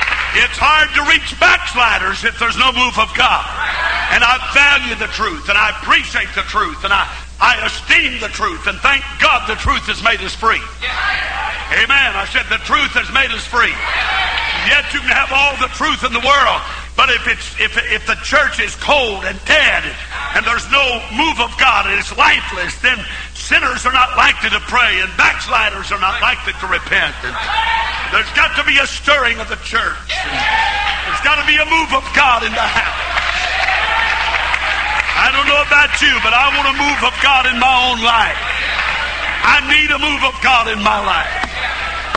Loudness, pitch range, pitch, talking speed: -13 LUFS, 245-300 Hz, 275 Hz, 195 wpm